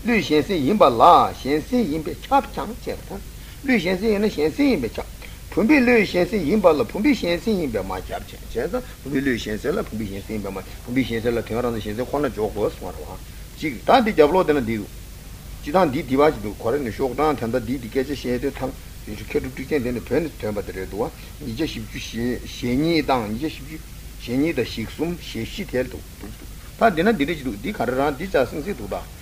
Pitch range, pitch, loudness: 110-160 Hz, 130 Hz, -22 LUFS